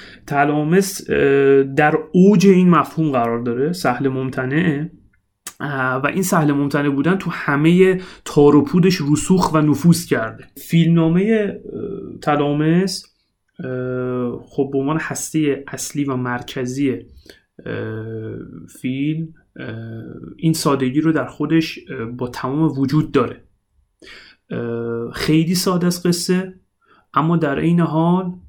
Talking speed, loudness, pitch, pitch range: 105 wpm, -18 LUFS, 150 Hz, 130-165 Hz